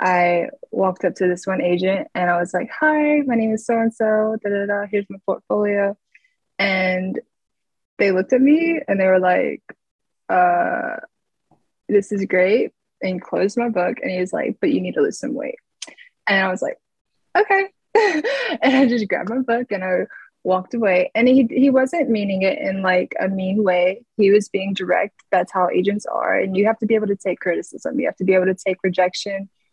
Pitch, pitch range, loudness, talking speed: 200 Hz, 185-255 Hz, -19 LUFS, 205 wpm